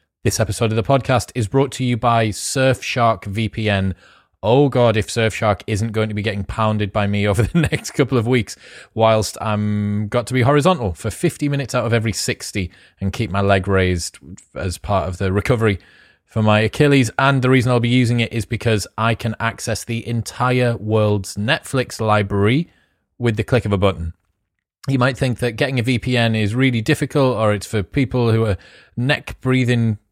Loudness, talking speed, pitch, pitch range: -18 LUFS, 195 wpm, 115 Hz, 105-125 Hz